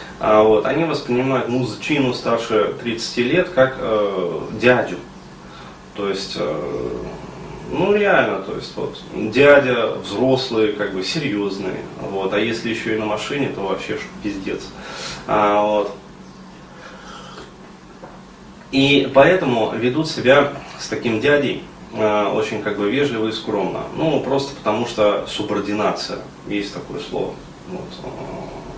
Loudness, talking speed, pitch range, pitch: -19 LUFS, 125 wpm, 105-140 Hz, 115 Hz